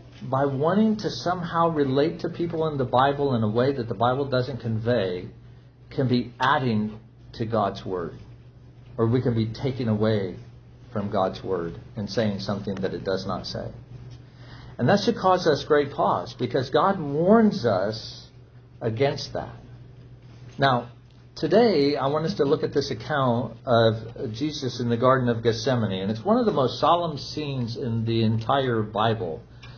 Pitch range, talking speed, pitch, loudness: 115-140 Hz, 165 wpm, 125 Hz, -24 LUFS